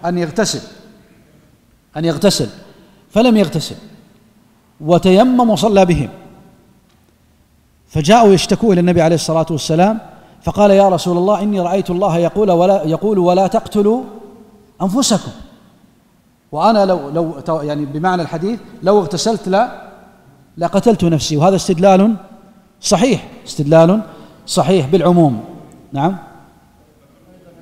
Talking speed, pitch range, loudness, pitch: 100 wpm, 165-205 Hz, -14 LUFS, 185 Hz